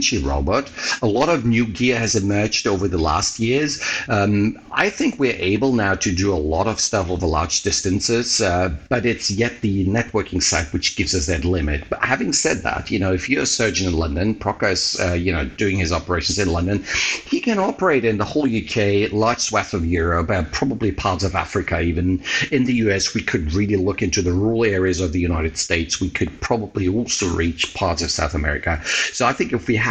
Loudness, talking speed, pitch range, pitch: -20 LUFS, 215 wpm, 85-110 Hz, 95 Hz